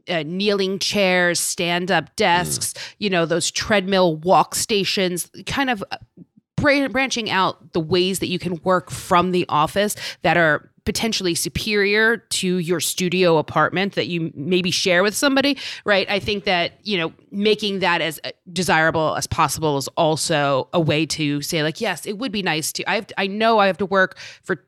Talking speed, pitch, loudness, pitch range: 180 wpm, 180 Hz, -20 LUFS, 165-200 Hz